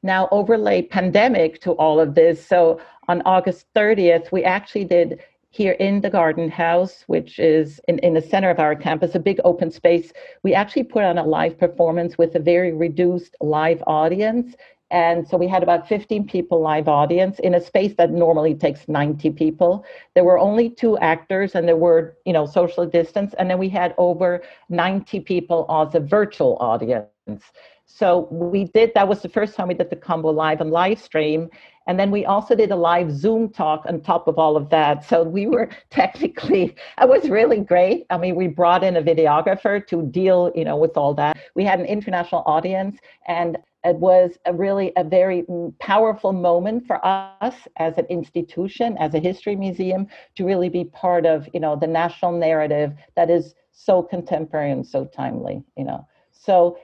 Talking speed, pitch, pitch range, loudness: 190 wpm, 175 Hz, 165-195 Hz, -19 LUFS